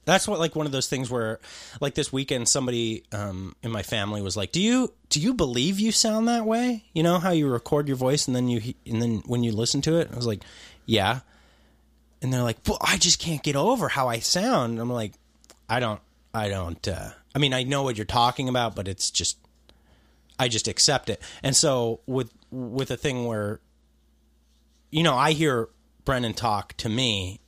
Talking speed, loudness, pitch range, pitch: 215 wpm, -25 LUFS, 100-145 Hz, 120 Hz